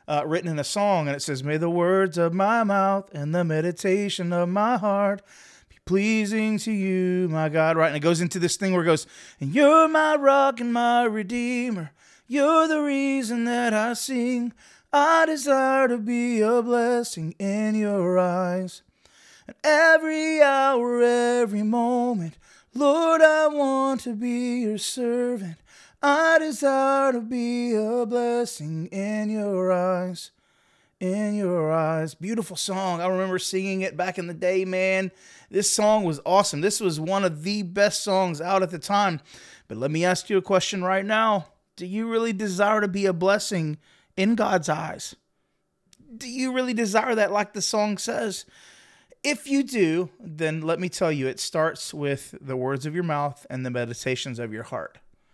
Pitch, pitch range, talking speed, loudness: 200 Hz, 175-240 Hz, 170 wpm, -23 LUFS